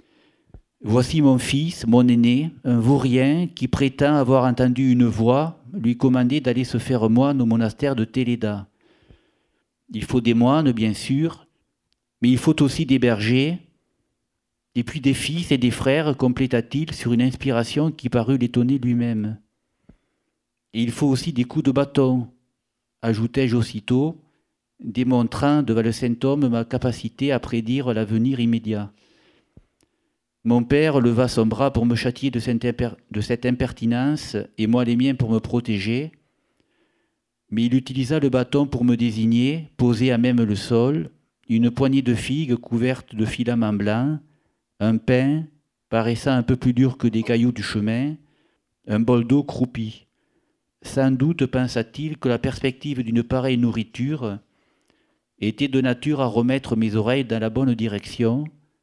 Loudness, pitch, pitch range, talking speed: -21 LUFS, 125 Hz, 115-135 Hz, 150 wpm